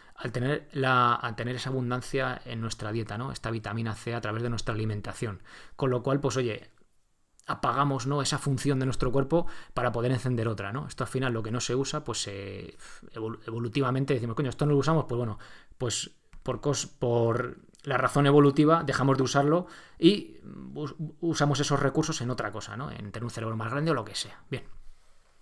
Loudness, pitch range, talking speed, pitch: -29 LUFS, 115-140 Hz, 200 wpm, 125 Hz